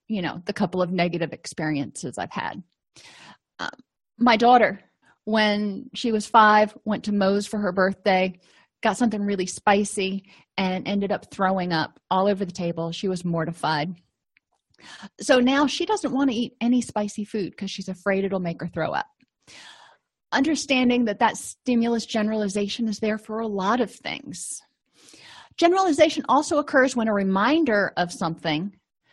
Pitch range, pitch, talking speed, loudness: 185-235 Hz, 205 Hz, 155 wpm, -23 LUFS